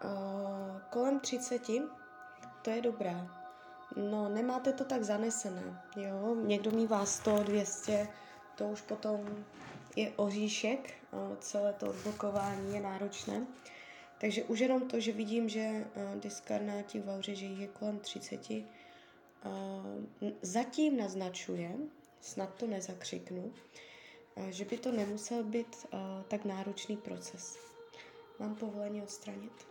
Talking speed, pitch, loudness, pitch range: 110 wpm, 210 Hz, -38 LUFS, 195-235 Hz